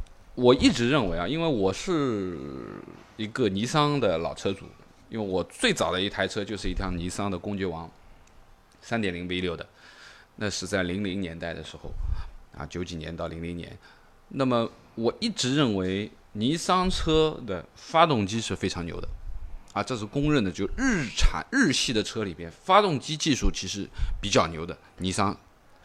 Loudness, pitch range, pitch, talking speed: -27 LUFS, 85-120 Hz, 95 Hz, 250 characters per minute